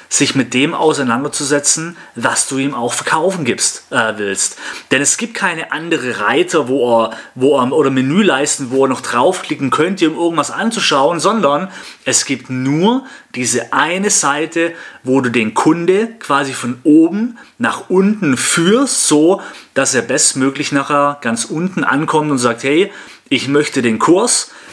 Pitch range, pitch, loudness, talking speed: 135-170 Hz, 145 Hz, -14 LUFS, 155 wpm